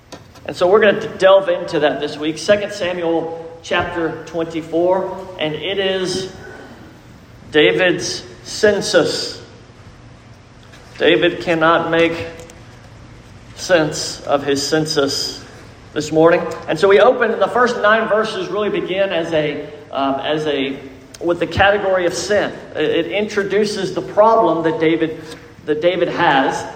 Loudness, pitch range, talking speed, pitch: -16 LUFS, 155-195 Hz, 130 wpm, 170 Hz